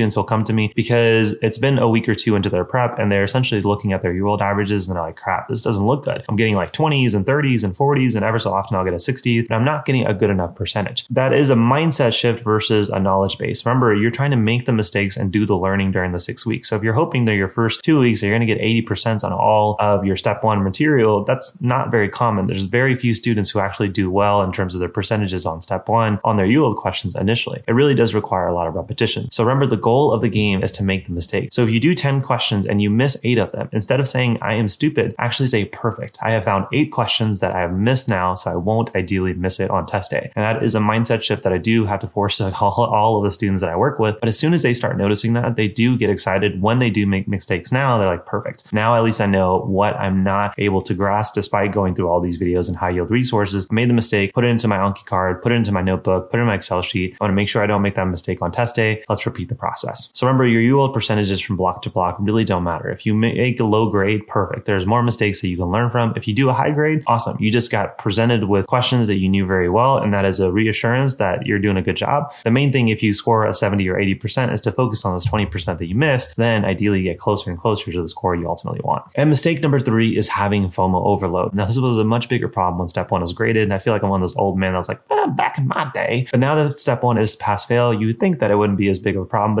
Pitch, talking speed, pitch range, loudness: 110 Hz, 290 wpm, 100-120 Hz, -18 LUFS